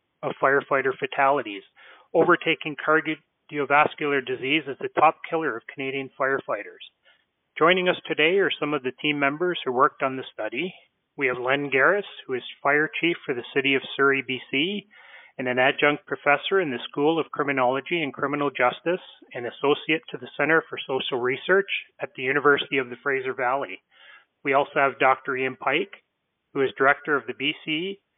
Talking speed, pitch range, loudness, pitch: 170 wpm, 135-160 Hz, -24 LUFS, 145 Hz